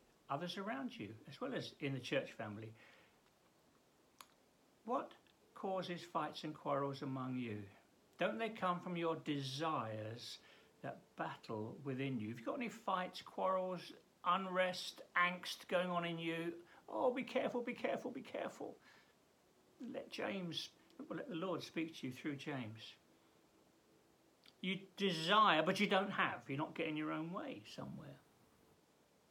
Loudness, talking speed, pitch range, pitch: -42 LUFS, 145 wpm, 135-190 Hz, 165 Hz